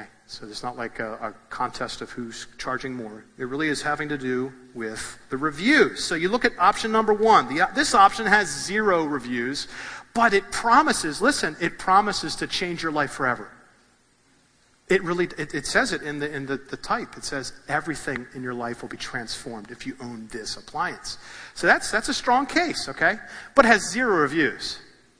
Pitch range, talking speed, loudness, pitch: 125-205 Hz, 195 wpm, -23 LUFS, 145 Hz